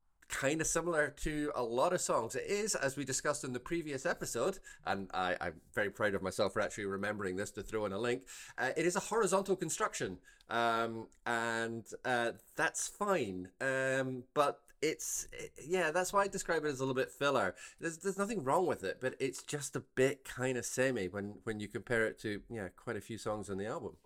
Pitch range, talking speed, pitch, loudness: 110-165 Hz, 215 wpm, 130 Hz, -36 LUFS